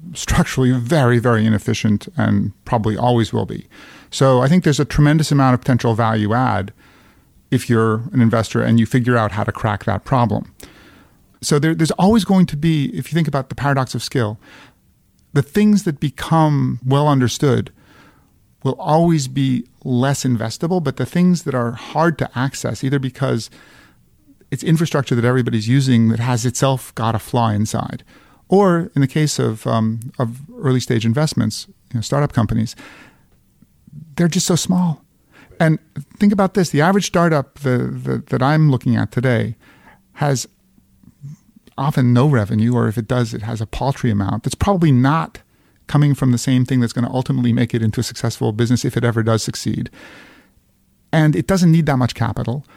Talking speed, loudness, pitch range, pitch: 175 wpm, -17 LUFS, 115-150 Hz, 130 Hz